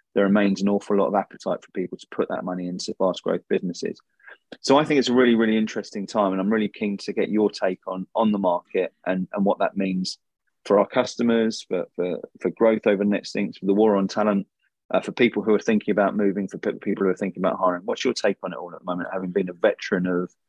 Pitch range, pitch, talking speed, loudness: 95-110 Hz, 100 Hz, 260 wpm, -23 LUFS